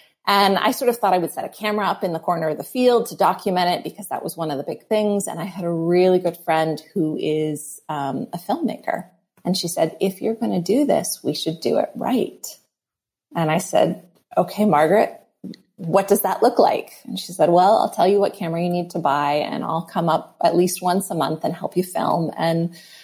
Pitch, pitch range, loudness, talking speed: 180 Hz, 160-200 Hz, -21 LUFS, 235 wpm